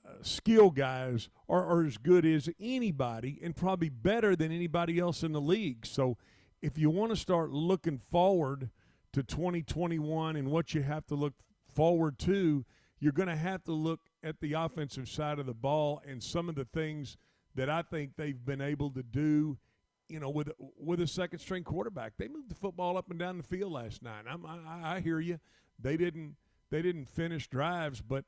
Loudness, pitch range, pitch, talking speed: -33 LUFS, 140-175 Hz, 155 Hz, 195 wpm